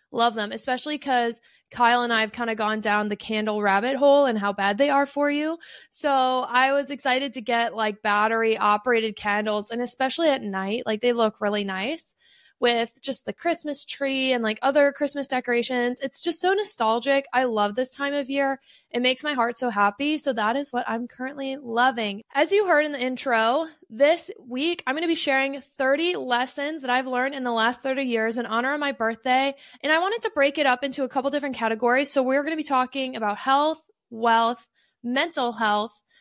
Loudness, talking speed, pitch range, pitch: -24 LUFS, 205 wpm, 230-280 Hz, 255 Hz